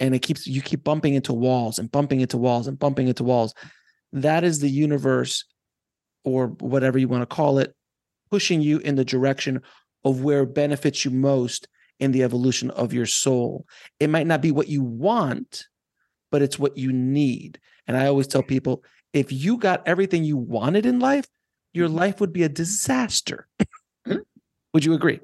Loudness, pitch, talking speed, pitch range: -22 LUFS, 140 Hz, 185 wpm, 130-155 Hz